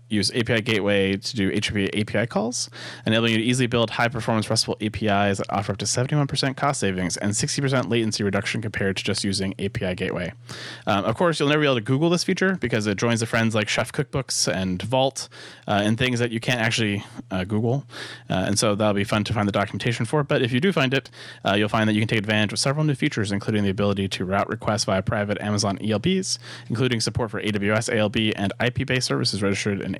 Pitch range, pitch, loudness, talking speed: 100-125 Hz, 110 Hz, -23 LUFS, 230 wpm